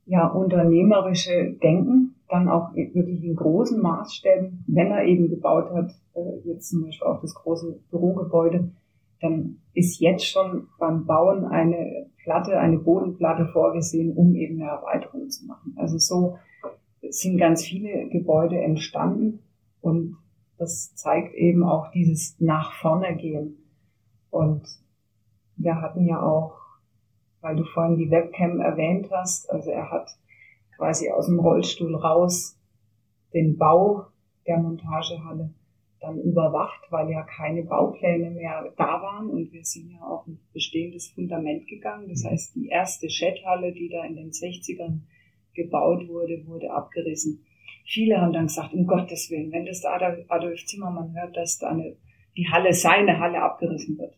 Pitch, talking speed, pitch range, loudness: 170 Hz, 145 wpm, 160-175 Hz, -24 LUFS